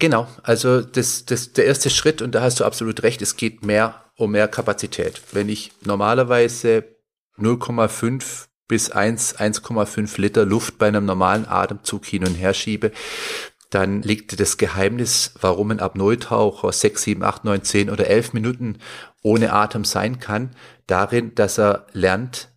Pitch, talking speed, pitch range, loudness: 110 Hz, 155 wpm, 100-120 Hz, -20 LUFS